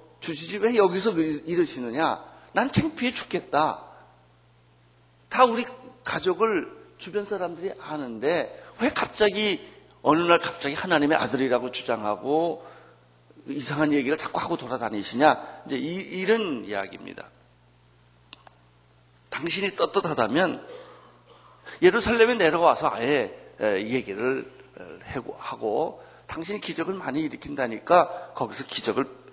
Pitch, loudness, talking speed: 170 Hz, -25 LUFS, 265 characters per minute